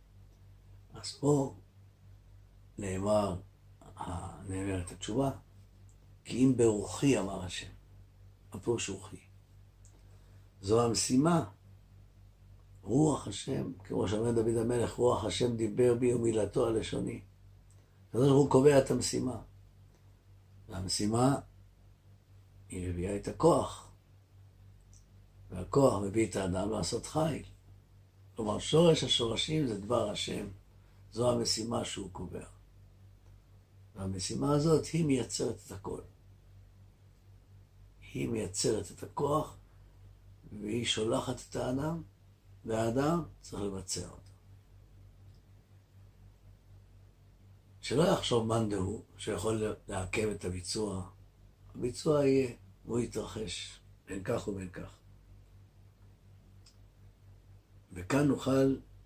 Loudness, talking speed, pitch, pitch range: -32 LUFS, 90 wpm, 100 Hz, 95-110 Hz